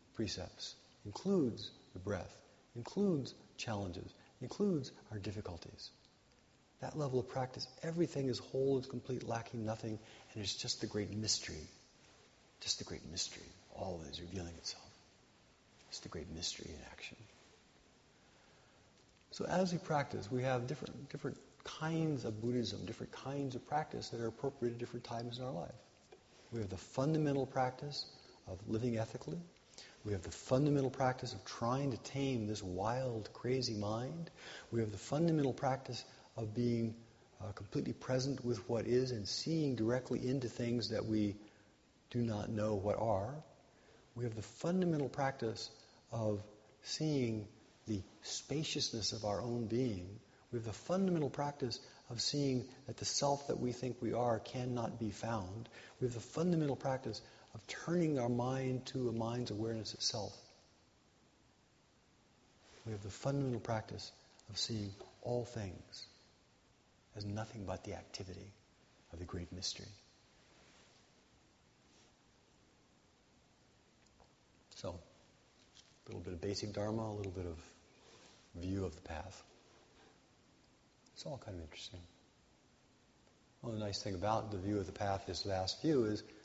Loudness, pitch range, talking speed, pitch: -40 LUFS, 105-130 Hz, 145 wpm, 115 Hz